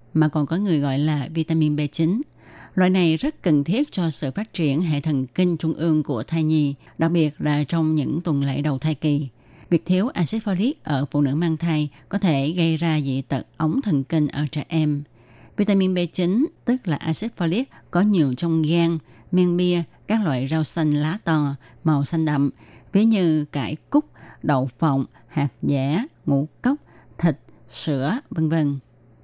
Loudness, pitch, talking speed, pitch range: -22 LUFS, 155 Hz, 185 wpm, 145-175 Hz